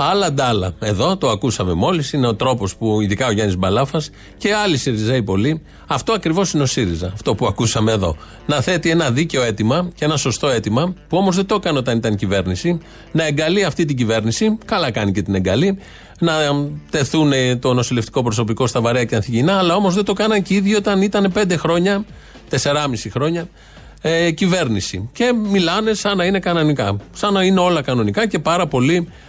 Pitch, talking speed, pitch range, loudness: 145 Hz, 190 wpm, 115-180 Hz, -17 LUFS